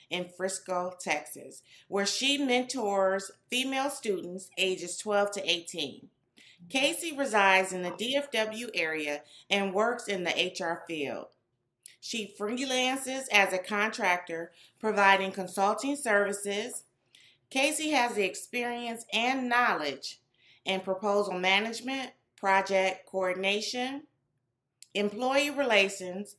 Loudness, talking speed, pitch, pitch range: -29 LUFS, 100 wpm, 200 Hz, 180-240 Hz